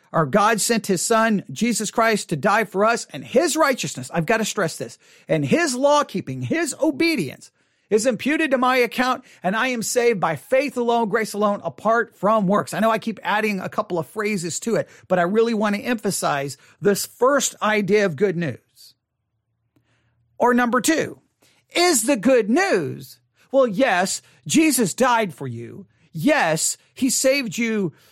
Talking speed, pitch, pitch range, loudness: 175 wpm, 215 Hz, 170-250 Hz, -20 LUFS